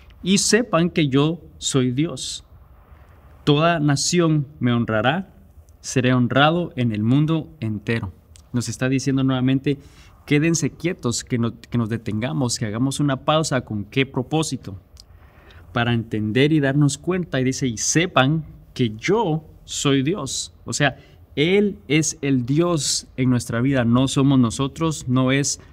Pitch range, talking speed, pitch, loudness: 115-150 Hz, 140 wpm, 130 Hz, -21 LUFS